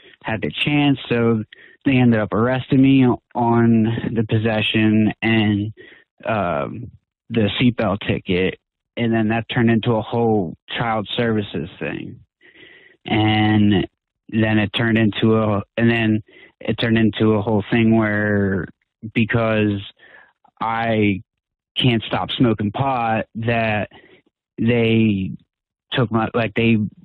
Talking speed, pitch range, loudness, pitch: 120 wpm, 105-115 Hz, -19 LUFS, 110 Hz